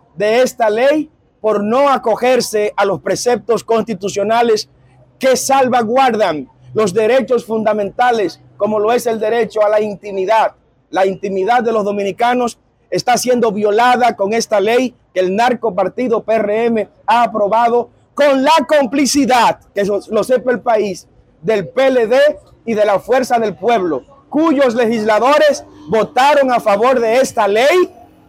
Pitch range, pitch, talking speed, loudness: 210-250 Hz, 225 Hz, 135 wpm, -14 LUFS